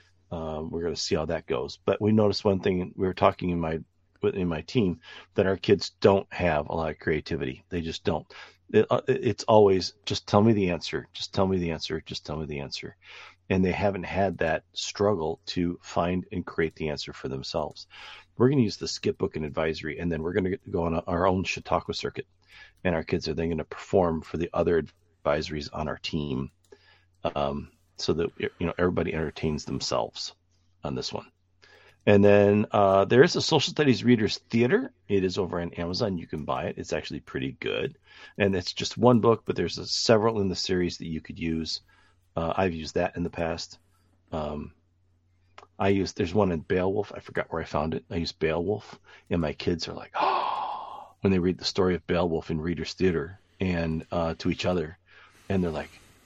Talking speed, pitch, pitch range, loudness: 210 wpm, 90 Hz, 80-95 Hz, -27 LUFS